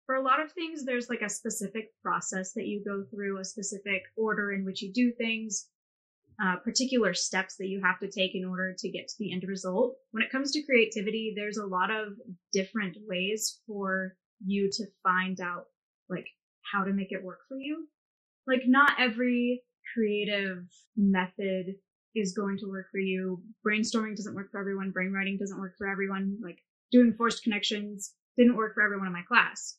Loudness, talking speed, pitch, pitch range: -30 LUFS, 190 wpm, 205 Hz, 190-230 Hz